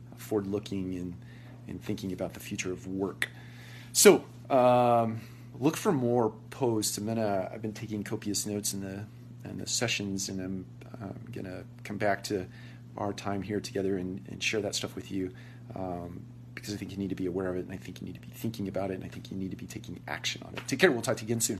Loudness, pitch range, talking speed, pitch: -31 LUFS, 95-120 Hz, 235 wpm, 105 Hz